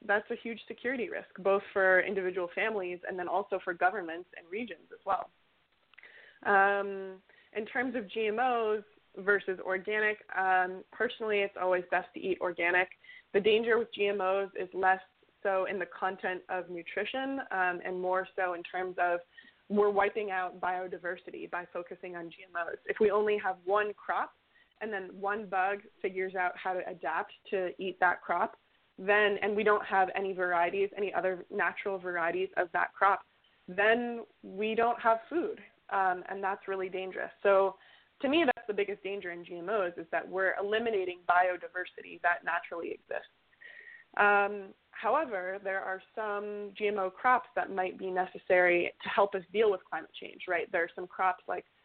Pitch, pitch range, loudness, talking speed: 195 Hz, 185-210 Hz, -32 LUFS, 165 wpm